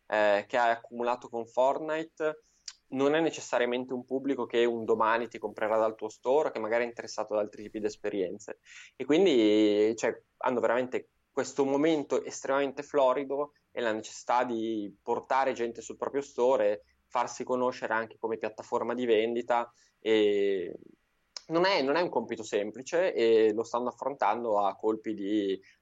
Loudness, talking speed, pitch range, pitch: -30 LUFS, 160 wpm, 110-145 Hz, 120 Hz